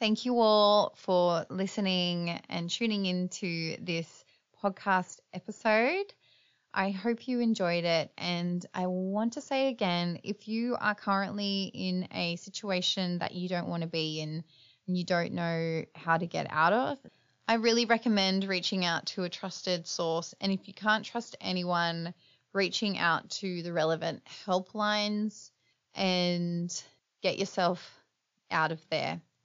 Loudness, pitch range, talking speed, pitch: -31 LUFS, 170-210 Hz, 150 wpm, 185 Hz